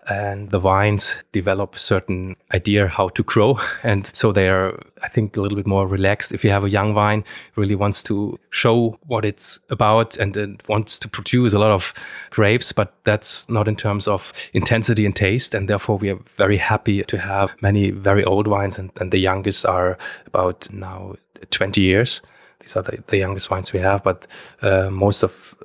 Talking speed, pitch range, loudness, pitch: 200 wpm, 95-105 Hz, -19 LUFS, 100 Hz